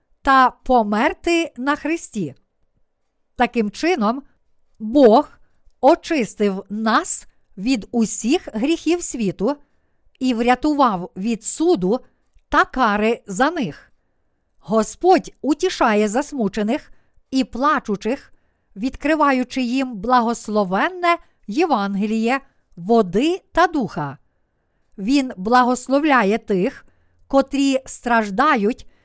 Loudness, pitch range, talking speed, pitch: -19 LUFS, 210-285 Hz, 80 wpm, 250 Hz